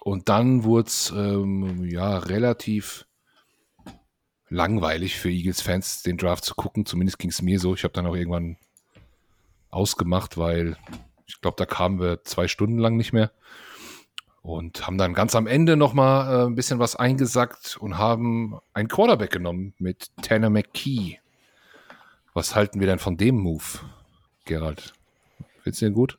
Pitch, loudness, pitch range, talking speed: 95 Hz, -24 LUFS, 90-115 Hz, 160 wpm